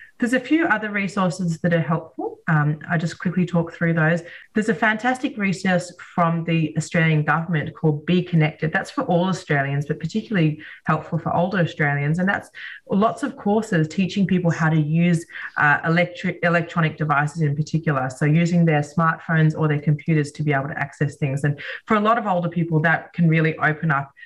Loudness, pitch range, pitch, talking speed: -21 LUFS, 155-185 Hz, 165 Hz, 190 wpm